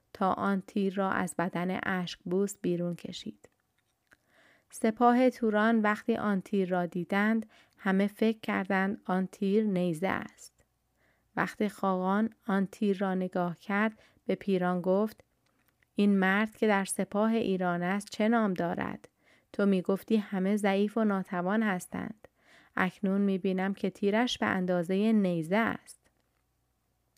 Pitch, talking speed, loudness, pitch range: 195 Hz, 135 wpm, -30 LUFS, 185-215 Hz